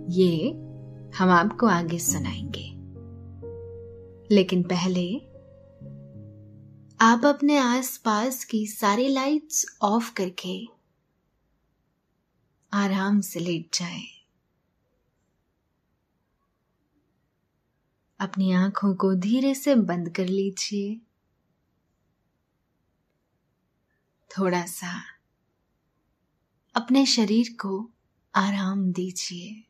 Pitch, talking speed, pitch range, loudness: 190 Hz, 70 wpm, 170-220 Hz, -24 LUFS